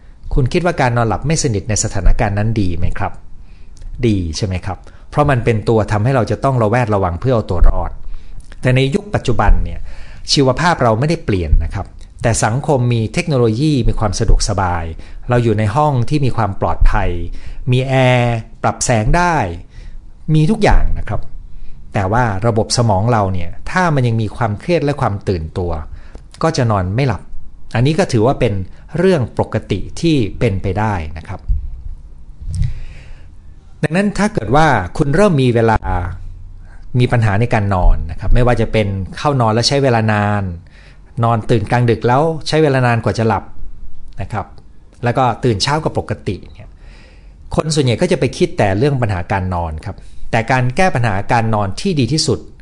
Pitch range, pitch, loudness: 90-125 Hz, 110 Hz, -16 LUFS